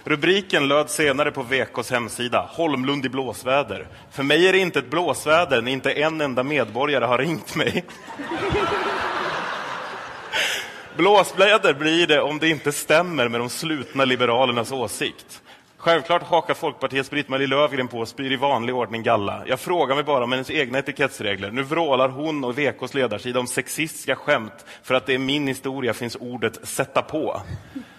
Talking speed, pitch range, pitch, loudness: 160 wpm, 125-150 Hz, 135 Hz, -22 LUFS